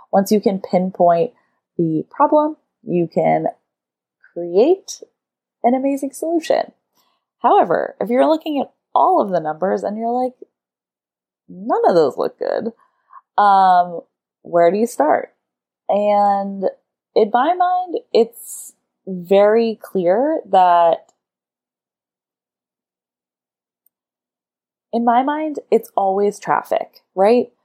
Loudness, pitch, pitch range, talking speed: -17 LUFS, 205 Hz, 175-290 Hz, 105 wpm